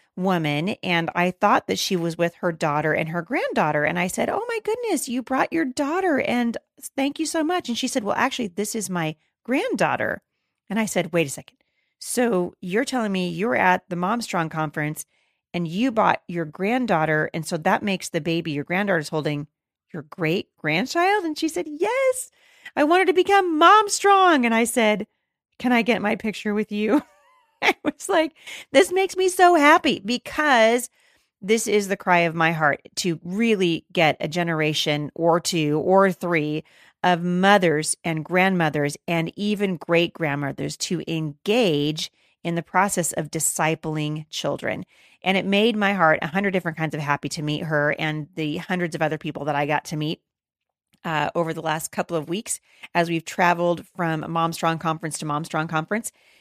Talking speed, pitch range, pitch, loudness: 185 wpm, 160-235 Hz, 180 Hz, -22 LUFS